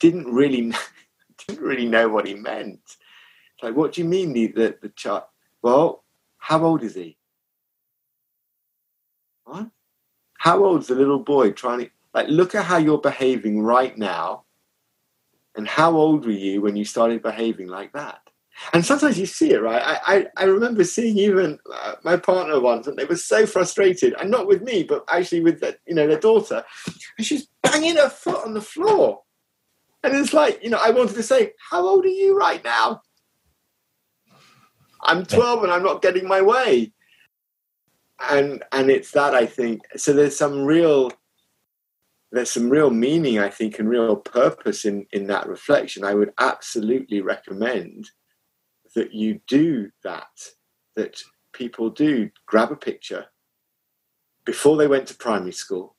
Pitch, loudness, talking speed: 165 Hz, -20 LUFS, 170 wpm